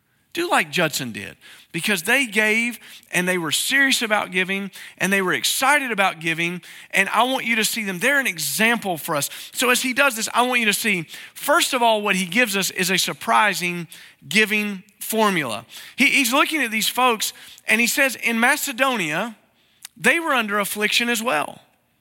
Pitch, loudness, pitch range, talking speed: 215 Hz, -19 LUFS, 185-250 Hz, 190 wpm